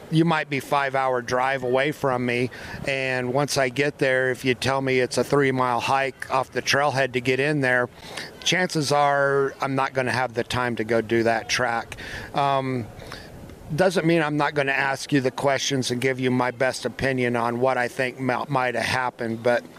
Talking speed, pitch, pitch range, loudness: 210 wpm, 130 Hz, 125-140 Hz, -23 LUFS